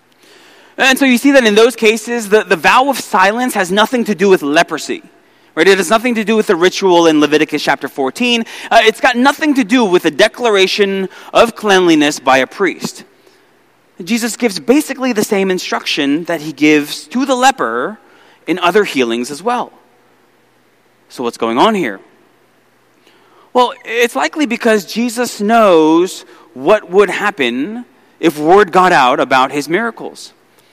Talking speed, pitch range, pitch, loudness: 165 wpm, 175-245 Hz, 215 Hz, -12 LUFS